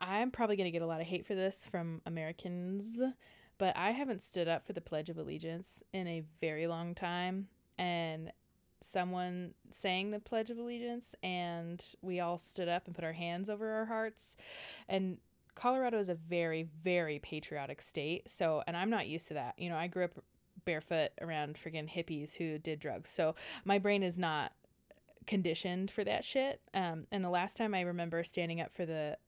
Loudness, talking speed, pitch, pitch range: -38 LUFS, 190 wpm, 180 Hz, 165-200 Hz